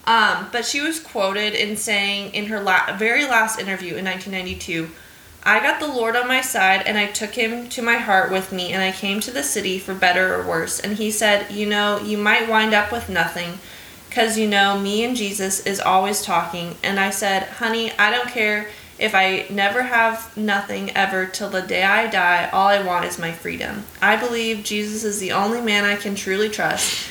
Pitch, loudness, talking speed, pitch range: 205 Hz, -19 LUFS, 215 wpm, 190-220 Hz